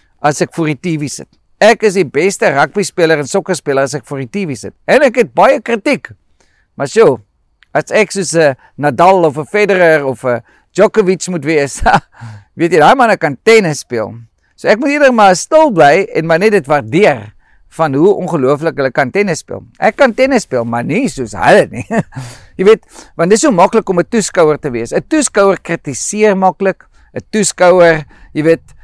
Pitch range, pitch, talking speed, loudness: 145-210 Hz, 175 Hz, 190 wpm, -11 LUFS